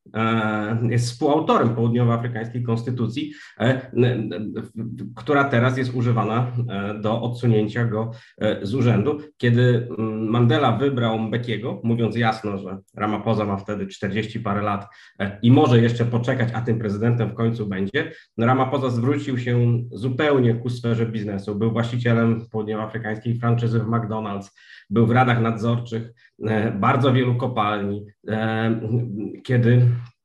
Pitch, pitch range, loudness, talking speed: 115 Hz, 110-120 Hz, -22 LUFS, 115 wpm